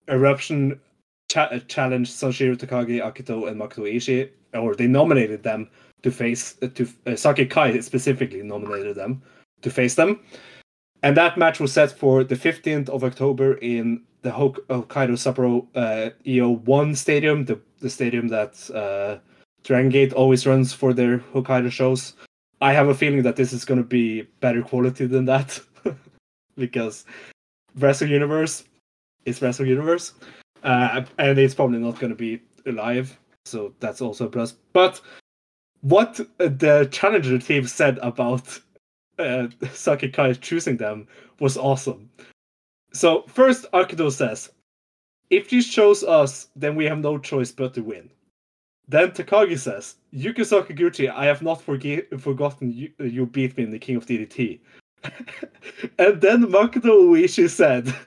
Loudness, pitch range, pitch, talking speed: -21 LUFS, 120-145 Hz, 130 Hz, 150 wpm